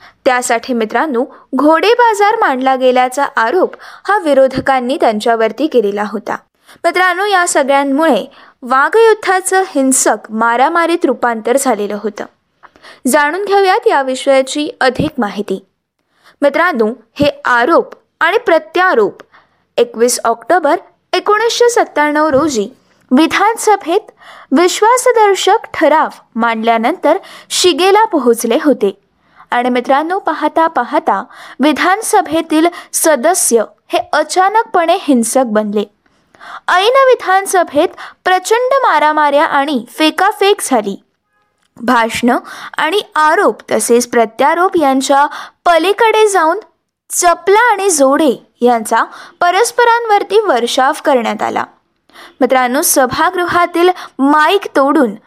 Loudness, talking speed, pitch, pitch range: -12 LUFS, 85 wpm, 305 Hz, 255-375 Hz